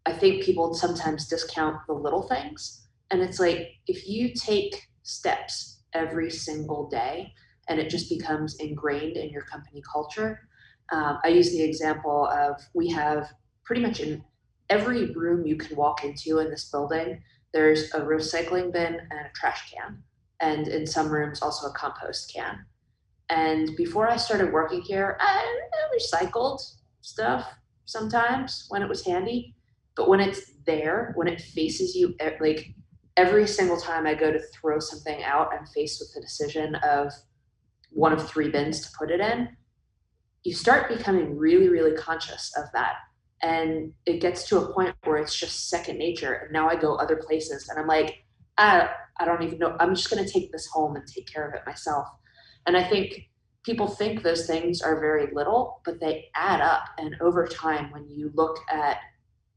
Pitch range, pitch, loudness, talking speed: 150-180 Hz, 160 Hz, -26 LUFS, 175 wpm